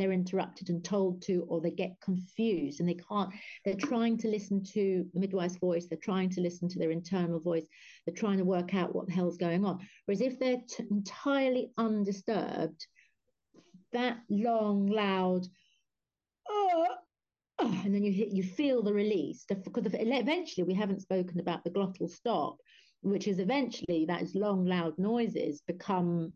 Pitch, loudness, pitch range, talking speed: 195 Hz, -33 LUFS, 180-225 Hz, 170 wpm